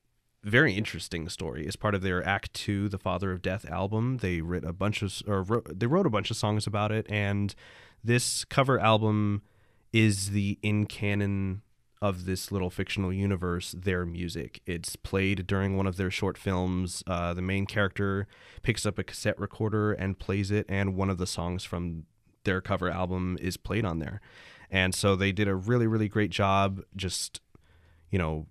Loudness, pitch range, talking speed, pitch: -29 LUFS, 90-105 Hz, 185 wpm, 100 Hz